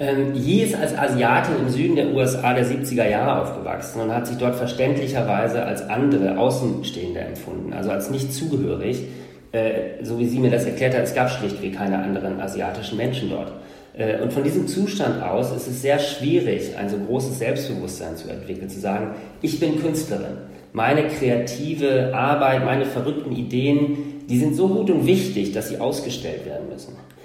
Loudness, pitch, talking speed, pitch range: -22 LUFS, 125 Hz, 170 wpm, 110-140 Hz